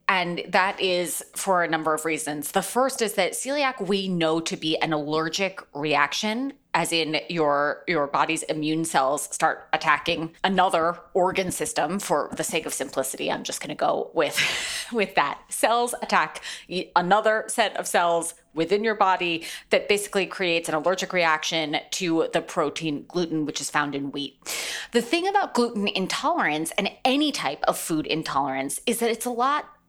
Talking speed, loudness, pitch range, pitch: 170 wpm, -24 LUFS, 155-200 Hz, 175 Hz